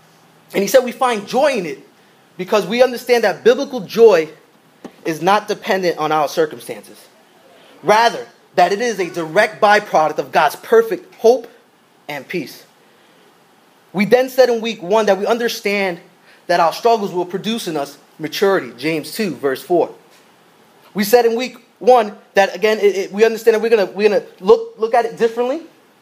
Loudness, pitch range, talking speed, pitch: -16 LUFS, 195-245 Hz, 175 wpm, 220 Hz